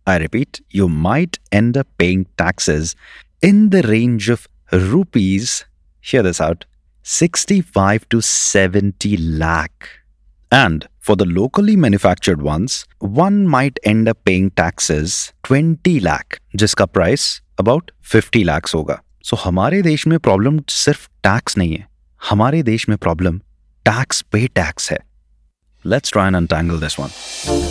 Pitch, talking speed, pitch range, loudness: 100 Hz, 135 wpm, 85-135 Hz, -16 LUFS